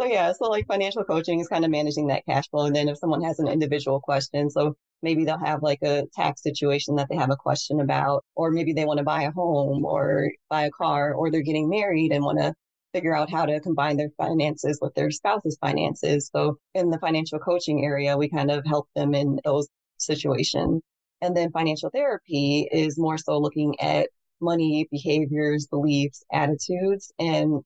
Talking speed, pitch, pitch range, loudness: 200 wpm, 150 Hz, 145-160 Hz, -24 LUFS